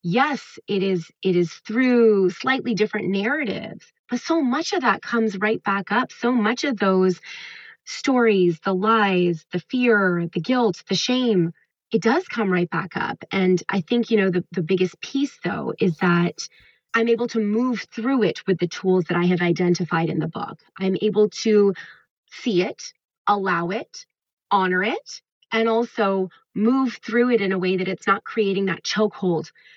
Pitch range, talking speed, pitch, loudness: 185-235 Hz, 175 wpm, 205 Hz, -22 LUFS